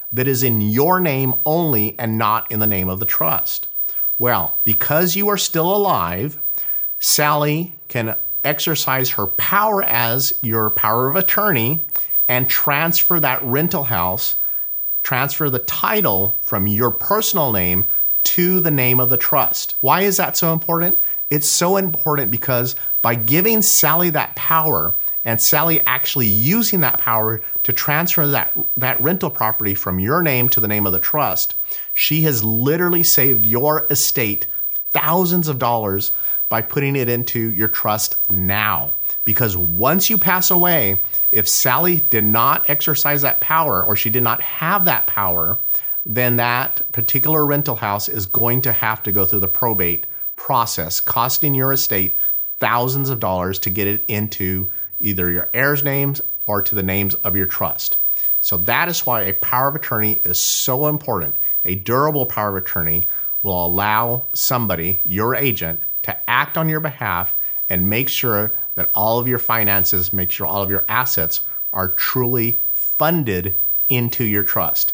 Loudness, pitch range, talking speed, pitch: -15 LUFS, 105-150 Hz, 160 wpm, 120 Hz